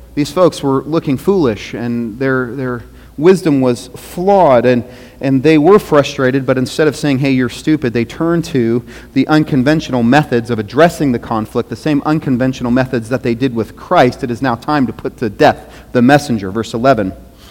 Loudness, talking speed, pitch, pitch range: -13 LUFS, 185 wpm, 130 Hz, 120-150 Hz